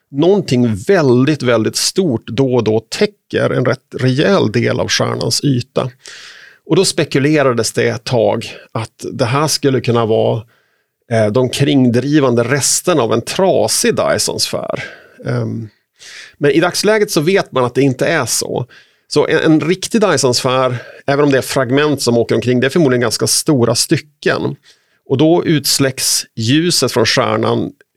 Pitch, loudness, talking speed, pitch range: 135 Hz, -14 LUFS, 150 wpm, 120-155 Hz